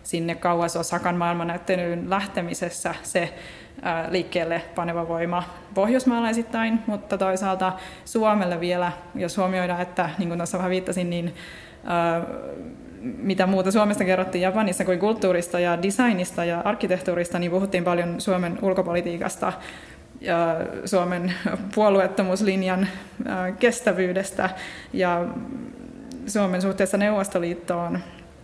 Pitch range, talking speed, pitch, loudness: 175-205 Hz, 95 wpm, 185 Hz, -24 LUFS